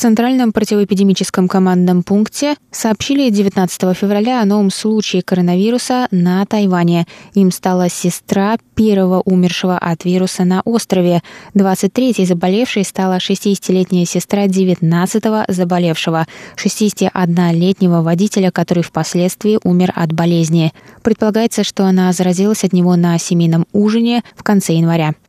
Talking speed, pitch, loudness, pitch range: 115 wpm, 190 Hz, -14 LUFS, 180-210 Hz